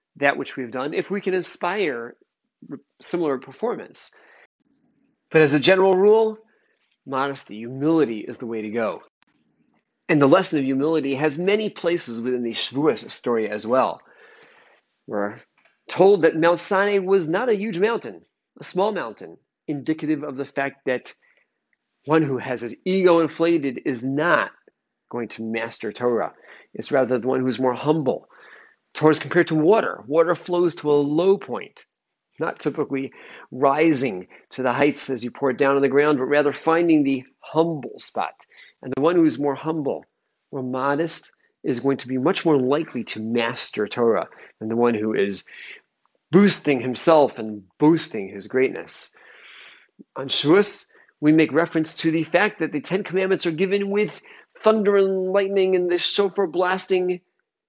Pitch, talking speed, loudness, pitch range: 150 Hz, 160 wpm, -21 LUFS, 130-180 Hz